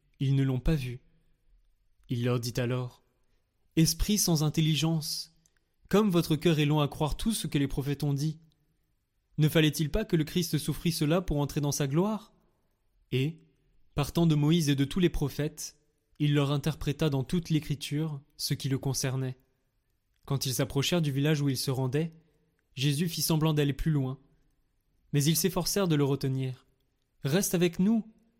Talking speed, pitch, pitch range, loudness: 175 wpm, 150 Hz, 135-160 Hz, -29 LUFS